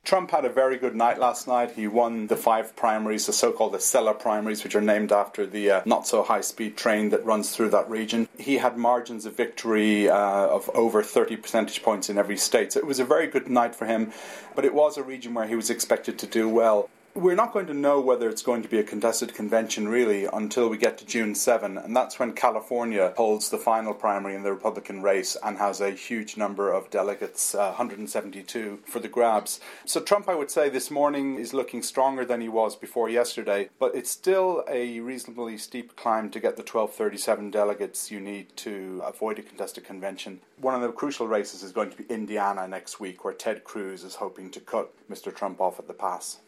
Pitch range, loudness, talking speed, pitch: 105-125 Hz, -26 LUFS, 225 wpm, 115 Hz